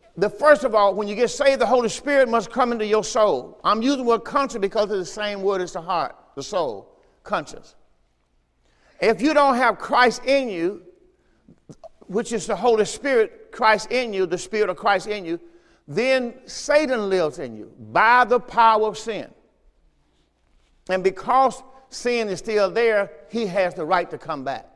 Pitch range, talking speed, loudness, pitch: 200-260 Hz, 185 wpm, -21 LUFS, 225 Hz